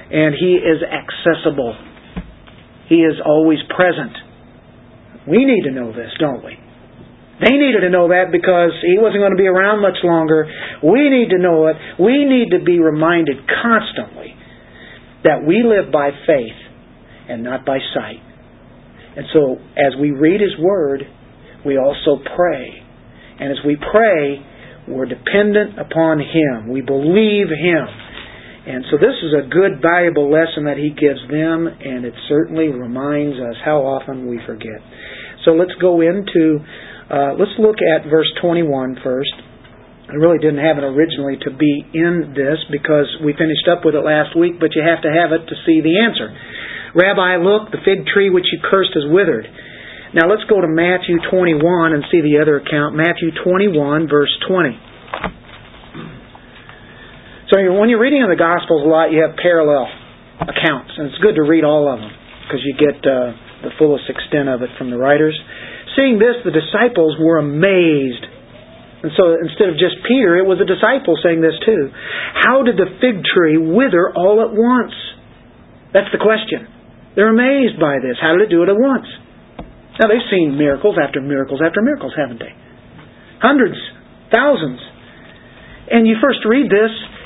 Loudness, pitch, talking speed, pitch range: -14 LUFS, 160 Hz, 170 wpm, 145-185 Hz